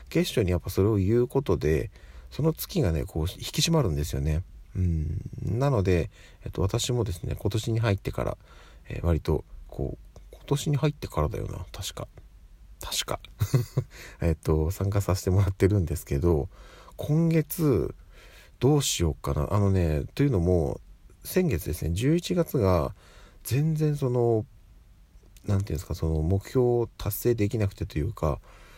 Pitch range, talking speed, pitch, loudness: 85-120 Hz, 285 characters per minute, 100 Hz, -27 LUFS